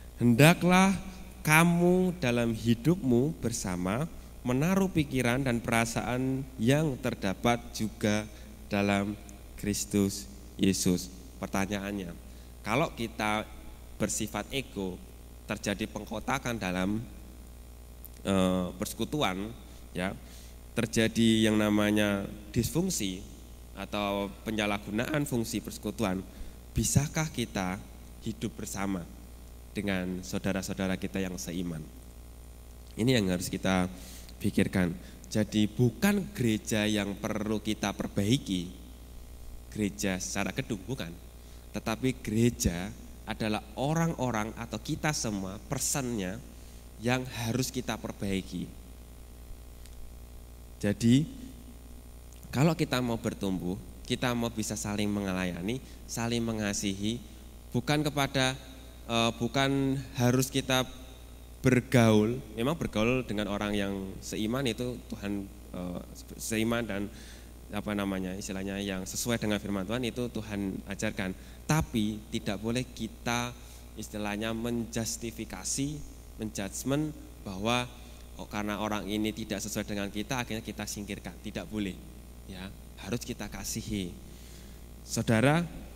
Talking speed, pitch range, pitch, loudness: 95 wpm, 90-115 Hz, 105 Hz, -31 LUFS